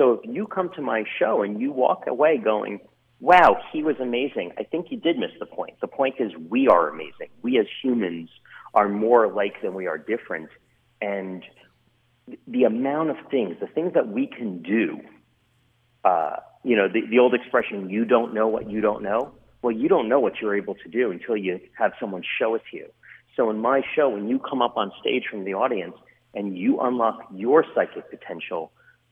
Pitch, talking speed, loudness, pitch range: 120 Hz, 205 wpm, -23 LUFS, 105-125 Hz